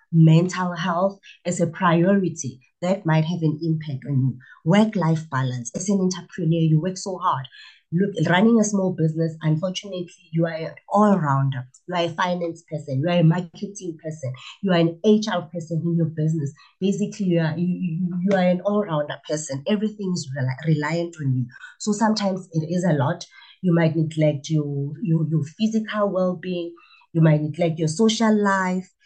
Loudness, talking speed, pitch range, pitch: -22 LUFS, 180 wpm, 155-185 Hz, 170 Hz